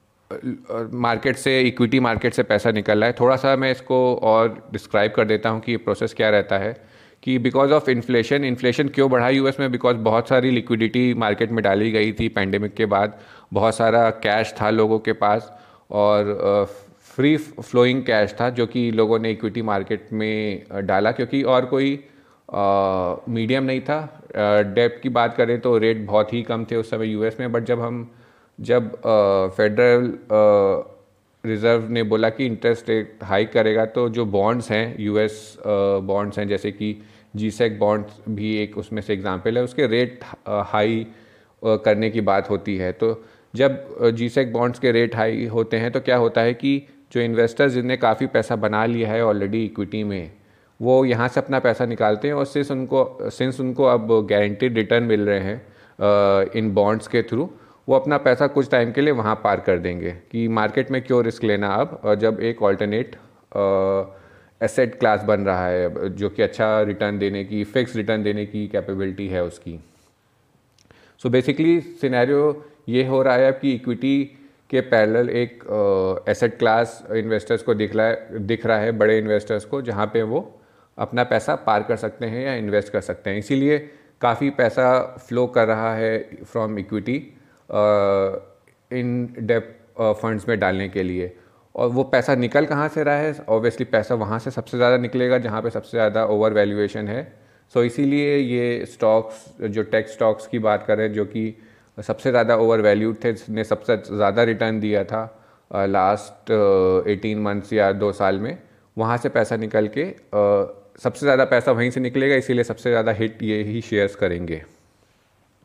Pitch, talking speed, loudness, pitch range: 115 Hz, 180 wpm, -21 LUFS, 105-125 Hz